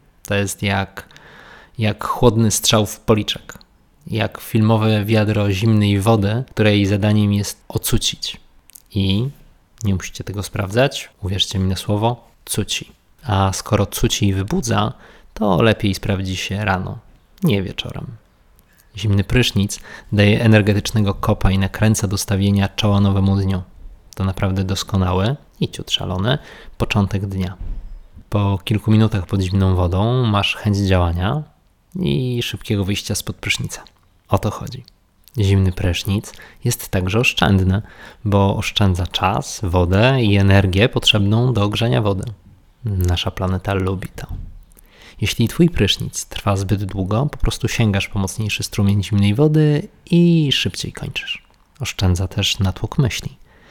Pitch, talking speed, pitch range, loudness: 100 Hz, 130 wpm, 95-110 Hz, -18 LUFS